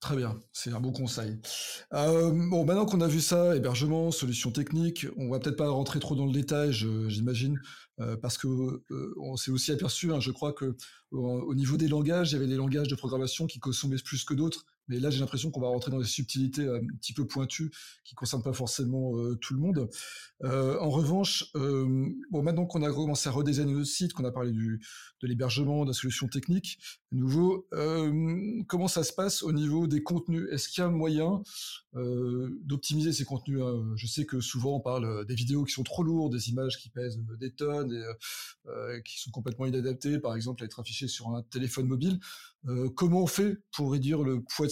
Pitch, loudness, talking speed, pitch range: 135 Hz, -31 LUFS, 215 wpm, 125-155 Hz